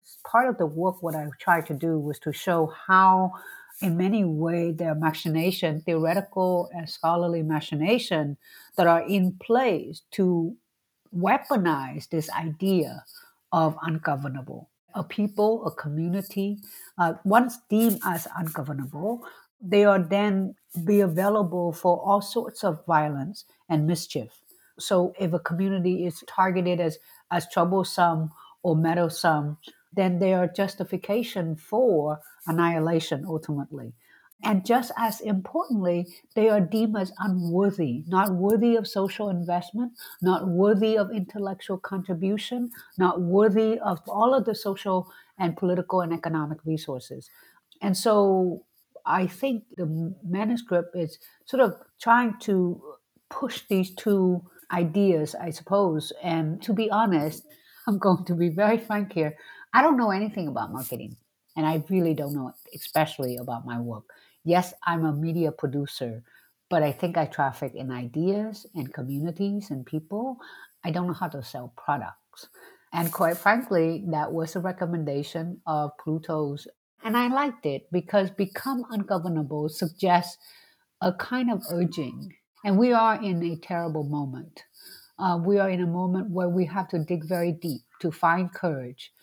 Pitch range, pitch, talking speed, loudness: 160-200 Hz, 180 Hz, 145 wpm, -26 LUFS